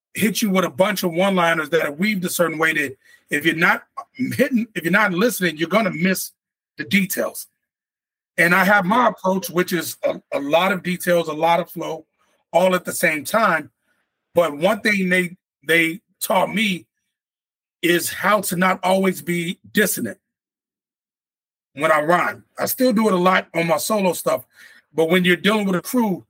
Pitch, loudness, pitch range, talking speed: 185 Hz, -19 LUFS, 170-210 Hz, 185 wpm